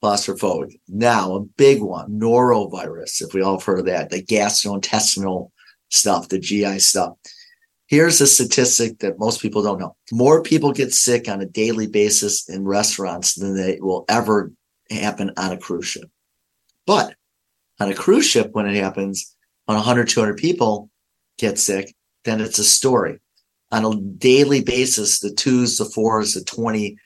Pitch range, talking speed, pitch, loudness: 100-120 Hz, 160 wpm, 105 Hz, -18 LUFS